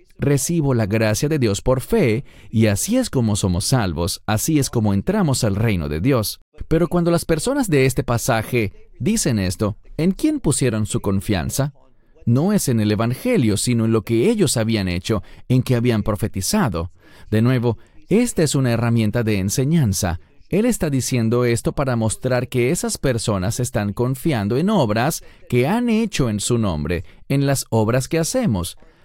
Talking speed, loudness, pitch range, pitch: 170 wpm, -20 LUFS, 105-145 Hz, 120 Hz